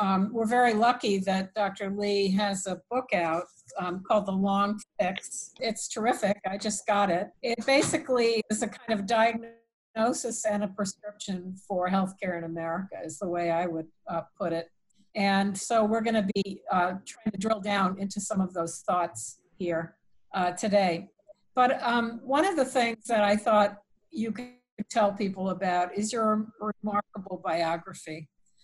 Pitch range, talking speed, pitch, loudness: 185-225 Hz, 170 wpm, 205 Hz, -28 LUFS